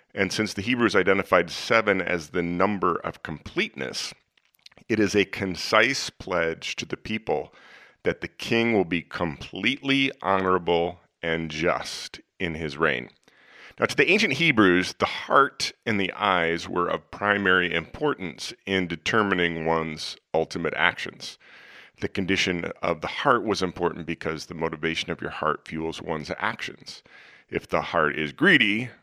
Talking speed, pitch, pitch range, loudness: 145 wpm, 90 Hz, 80-100 Hz, -25 LUFS